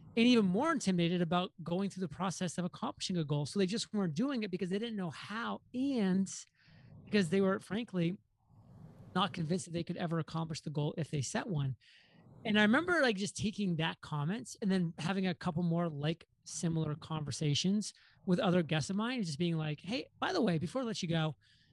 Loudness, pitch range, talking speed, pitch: -35 LUFS, 160-205 Hz, 210 wpm, 180 Hz